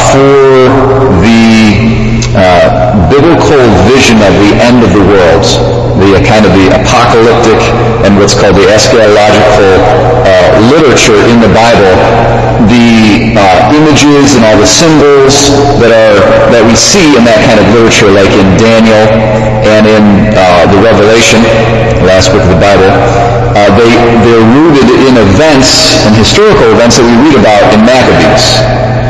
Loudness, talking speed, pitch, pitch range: -3 LUFS, 150 wpm, 115 Hz, 105-120 Hz